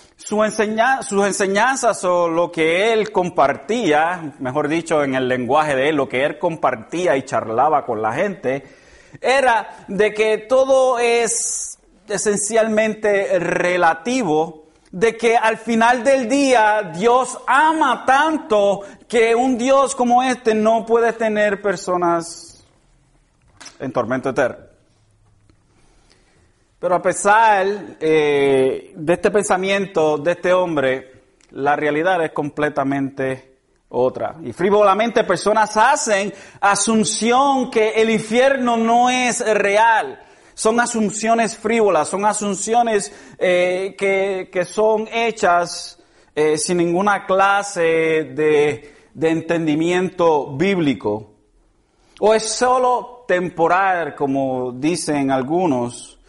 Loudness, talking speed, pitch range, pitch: -18 LUFS, 110 wpm, 155-225 Hz, 195 Hz